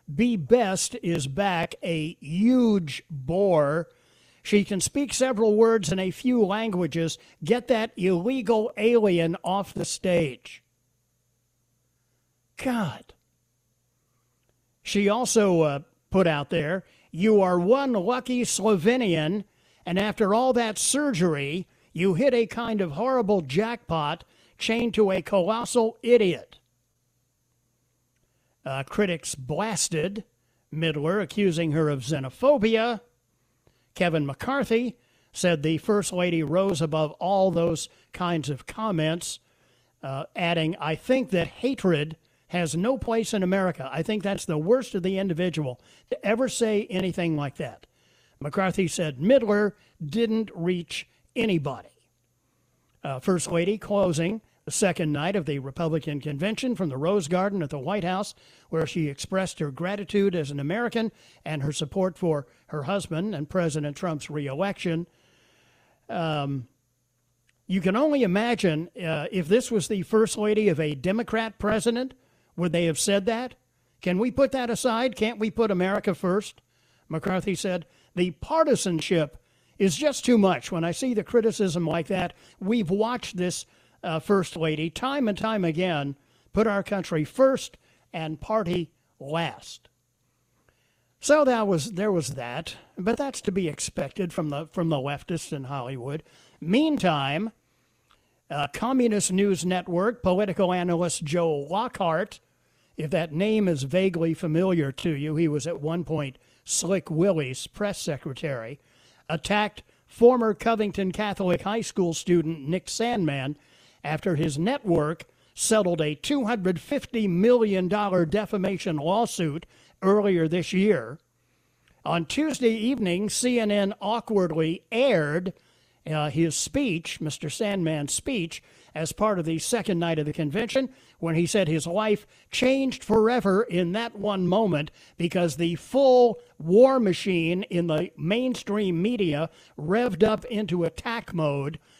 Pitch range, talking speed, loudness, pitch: 155-215 Hz, 135 wpm, -25 LUFS, 180 Hz